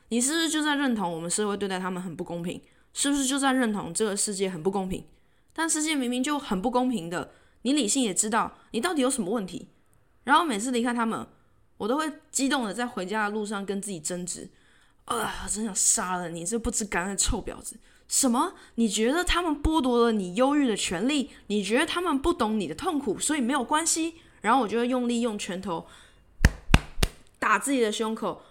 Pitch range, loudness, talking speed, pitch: 200-280 Hz, -26 LUFS, 315 characters per minute, 235 Hz